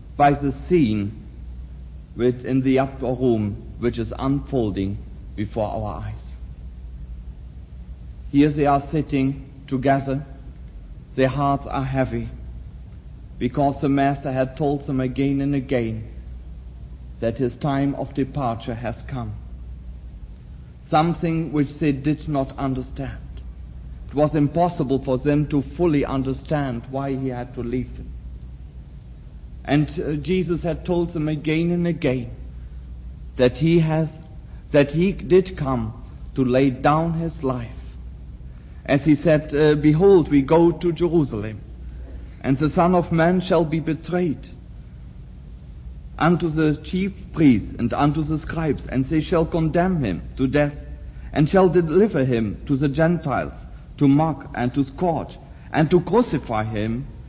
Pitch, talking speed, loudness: 135 Hz, 130 wpm, -21 LUFS